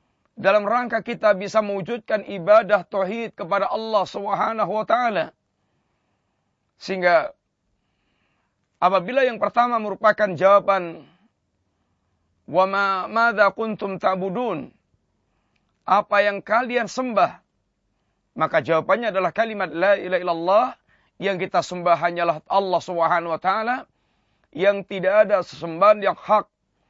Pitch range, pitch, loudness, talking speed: 180-220 Hz, 200 Hz, -21 LUFS, 105 wpm